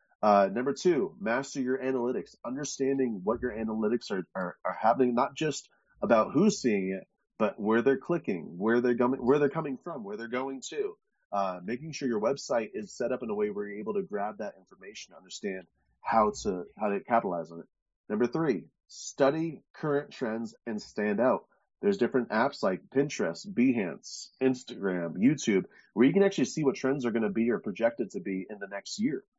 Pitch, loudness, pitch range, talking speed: 130 Hz, -30 LUFS, 110-160 Hz, 195 wpm